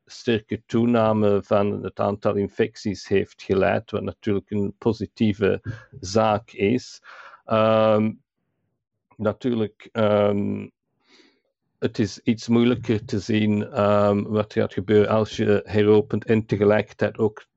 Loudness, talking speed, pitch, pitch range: -22 LUFS, 115 wpm, 105 Hz, 105-110 Hz